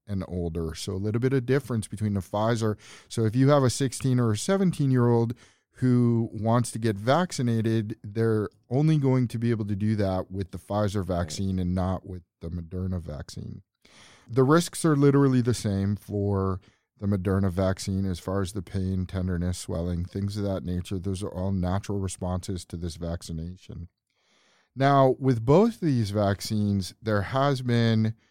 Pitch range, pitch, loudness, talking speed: 95-120 Hz, 105 Hz, -26 LUFS, 180 wpm